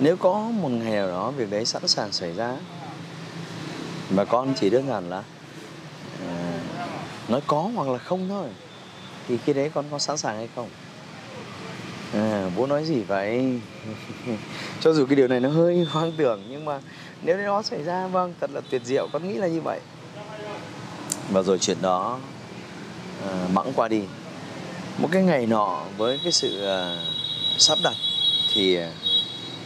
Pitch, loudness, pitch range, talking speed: 145 Hz, -24 LUFS, 110-165 Hz, 170 wpm